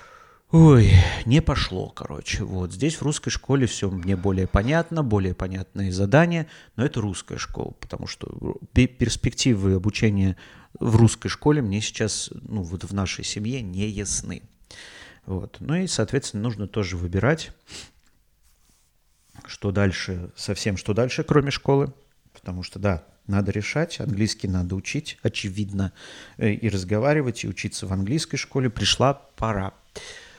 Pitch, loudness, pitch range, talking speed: 105 Hz, -24 LUFS, 95-135 Hz, 135 wpm